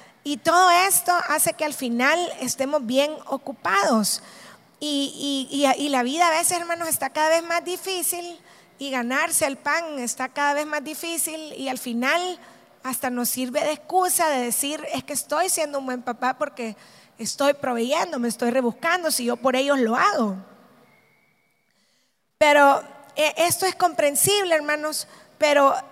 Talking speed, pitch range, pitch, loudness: 155 wpm, 255-325 Hz, 290 Hz, -22 LUFS